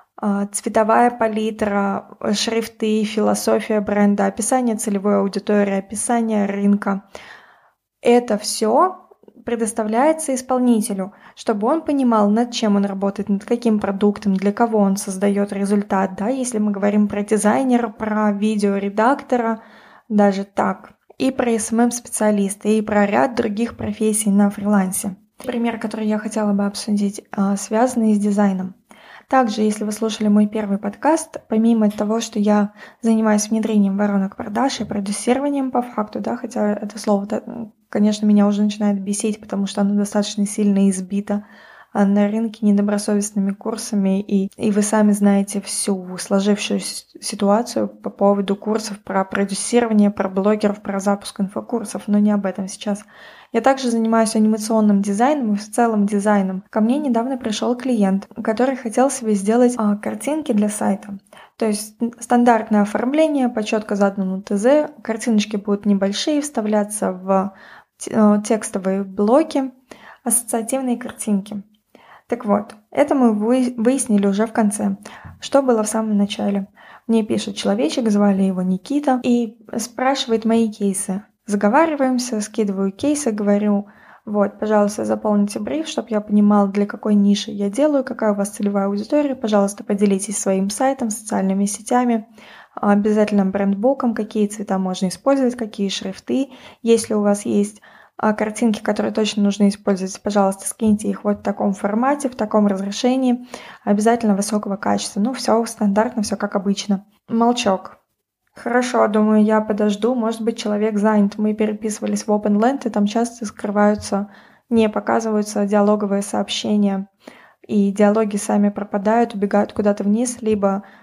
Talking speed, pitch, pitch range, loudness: 135 wpm, 215 Hz, 205-230 Hz, -19 LUFS